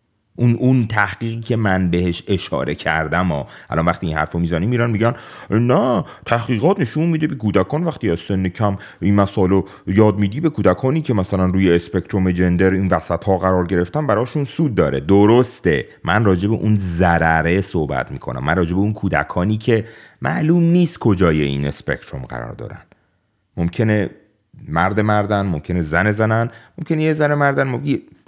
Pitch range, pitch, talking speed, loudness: 90-120 Hz, 100 Hz, 170 wpm, -18 LUFS